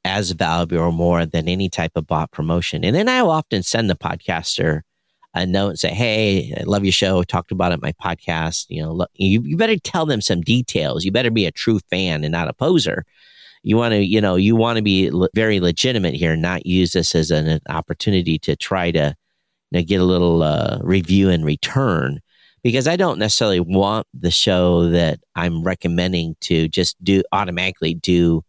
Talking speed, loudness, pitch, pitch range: 215 wpm, -18 LUFS, 90 Hz, 85-100 Hz